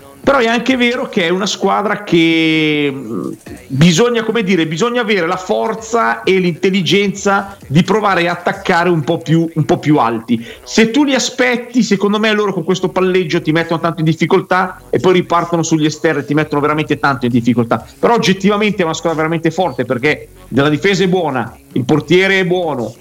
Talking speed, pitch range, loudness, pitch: 190 wpm, 155-200 Hz, -14 LUFS, 175 Hz